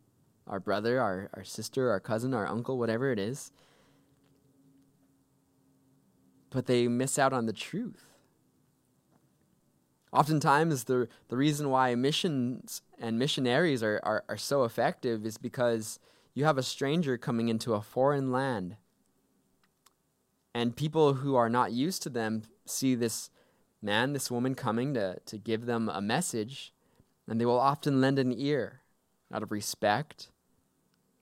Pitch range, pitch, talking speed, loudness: 110-135 Hz, 125 Hz, 140 wpm, -30 LUFS